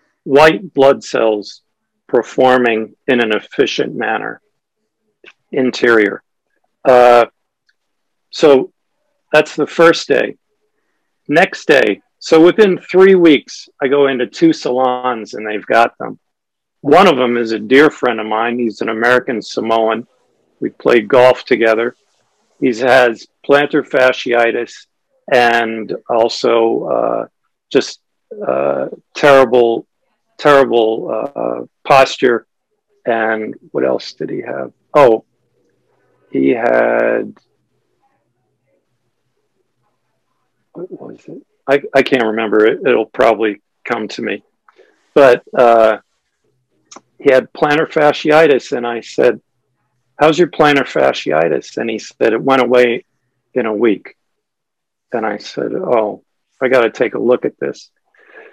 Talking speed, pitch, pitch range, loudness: 120 wpm, 125 Hz, 115-155 Hz, -13 LUFS